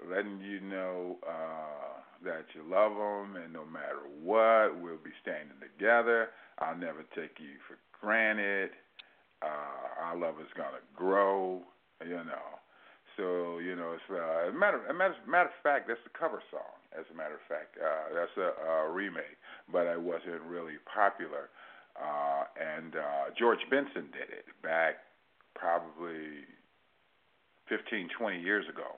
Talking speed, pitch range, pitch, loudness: 155 wpm, 80-110 Hz, 90 Hz, -34 LUFS